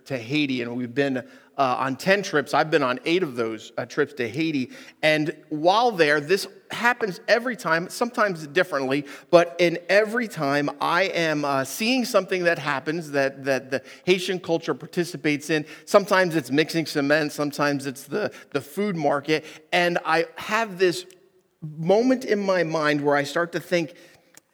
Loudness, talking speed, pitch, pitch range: -23 LUFS, 170 wpm, 160 Hz, 145-185 Hz